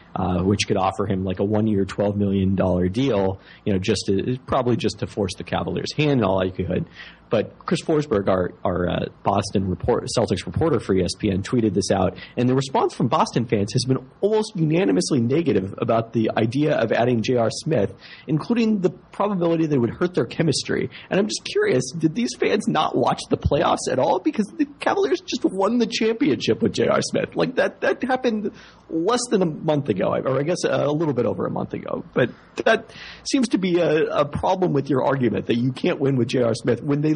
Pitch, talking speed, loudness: 130 Hz, 210 wpm, -22 LUFS